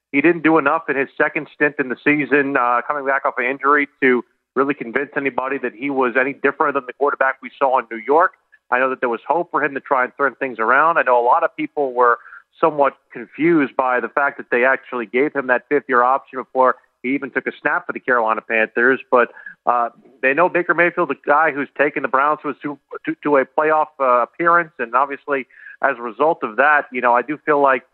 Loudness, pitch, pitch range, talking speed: -18 LUFS, 140 Hz, 130-150 Hz, 245 wpm